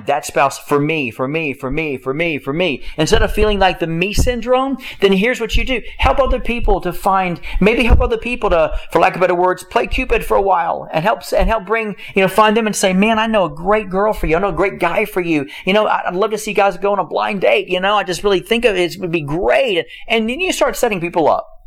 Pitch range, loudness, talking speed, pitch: 175-225 Hz, -16 LUFS, 285 wpm, 200 Hz